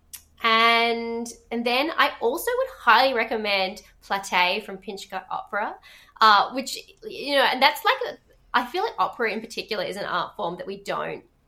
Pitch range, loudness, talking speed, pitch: 195-285 Hz, -23 LUFS, 175 wpm, 230 Hz